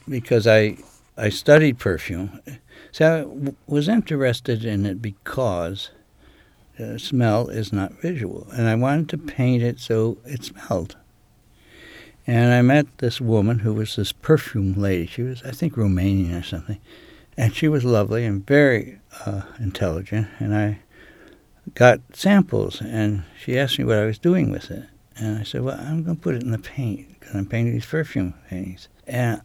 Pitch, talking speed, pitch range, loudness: 115 Hz, 175 wpm, 105-135 Hz, -21 LUFS